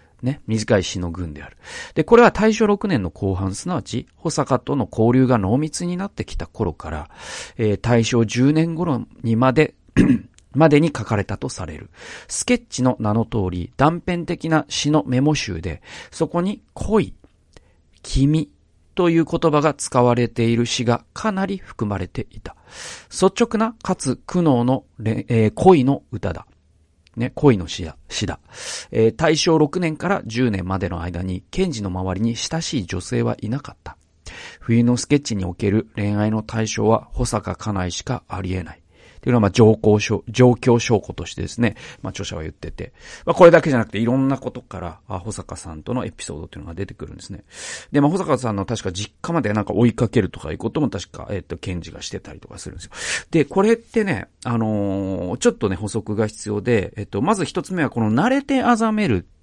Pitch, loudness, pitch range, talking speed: 115 Hz, -20 LUFS, 95-150 Hz, 340 characters per minute